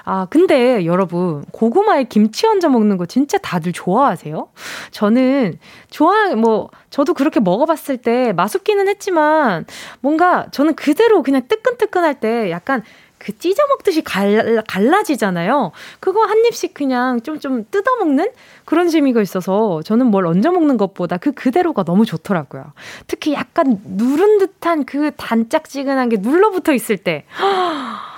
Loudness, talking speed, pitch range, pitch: -16 LUFS, 305 characters per minute, 215-335 Hz, 270 Hz